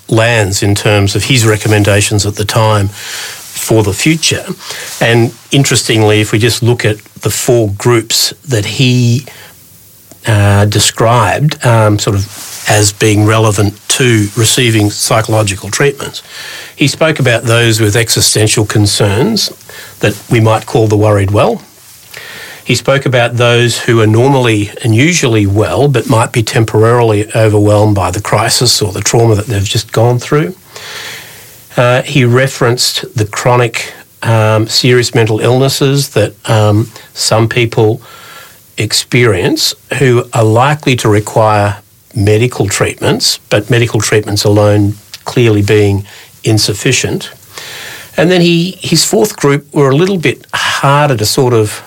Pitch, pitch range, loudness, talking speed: 115 Hz, 105-130 Hz, -10 LUFS, 135 wpm